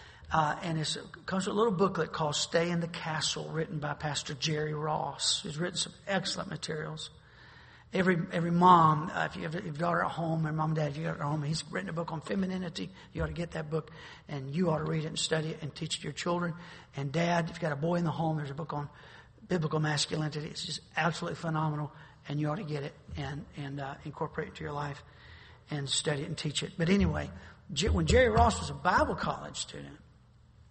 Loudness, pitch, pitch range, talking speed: -32 LUFS, 155 Hz, 145-170 Hz, 235 wpm